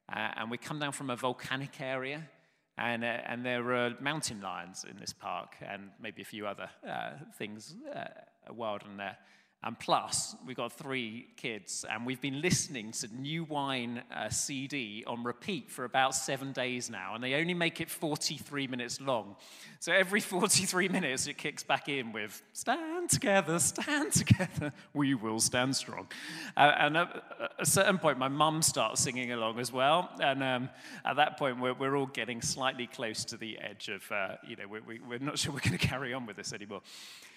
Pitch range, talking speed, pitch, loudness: 120-150 Hz, 195 wpm, 130 Hz, -33 LUFS